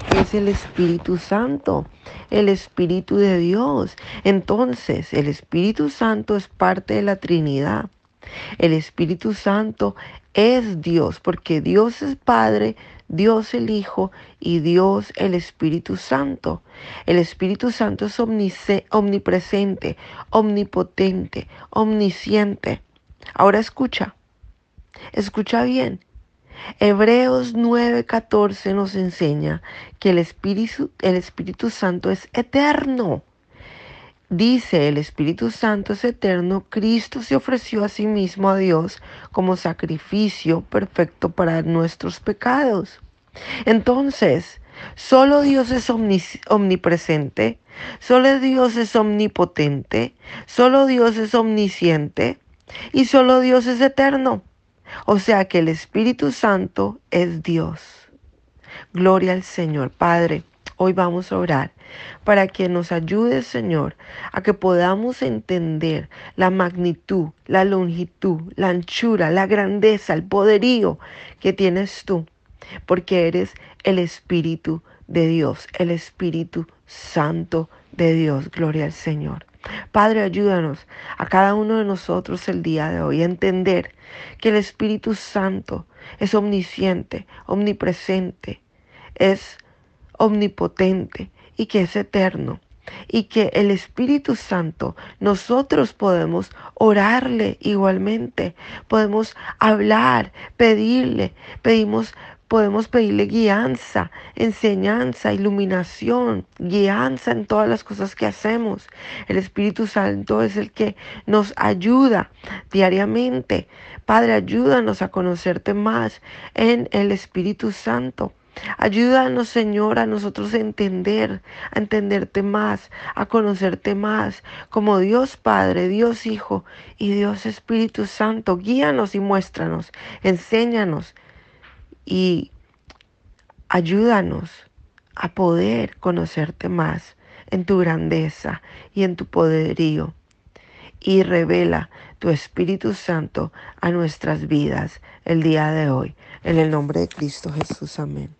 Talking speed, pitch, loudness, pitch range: 110 wpm, 195 Hz, -19 LUFS, 170-220 Hz